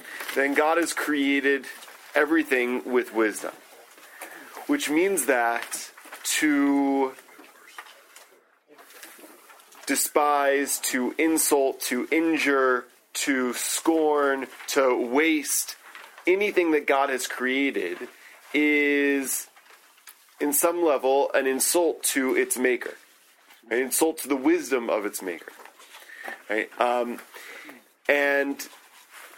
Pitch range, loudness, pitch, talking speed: 135-160 Hz, -24 LUFS, 145 Hz, 95 wpm